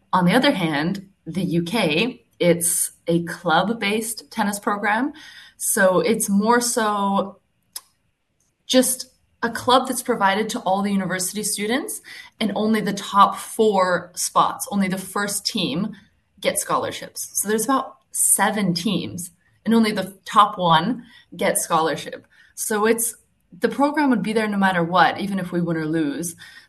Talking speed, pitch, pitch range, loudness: 145 wpm, 205 Hz, 185-230 Hz, -21 LUFS